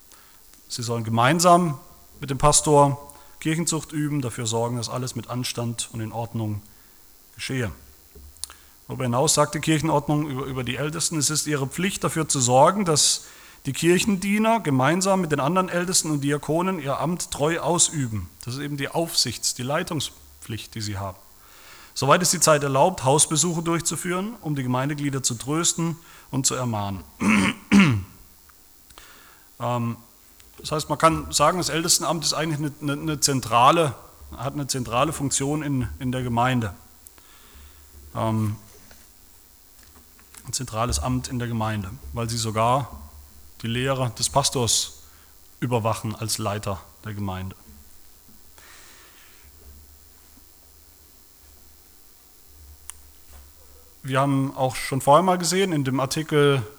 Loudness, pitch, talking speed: -23 LUFS, 125 Hz, 130 wpm